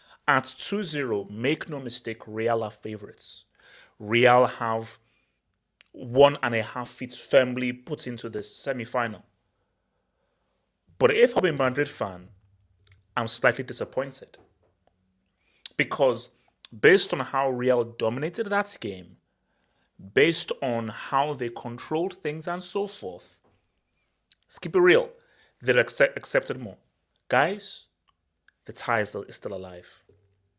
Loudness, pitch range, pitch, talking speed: -25 LUFS, 105-150 Hz, 120 Hz, 115 wpm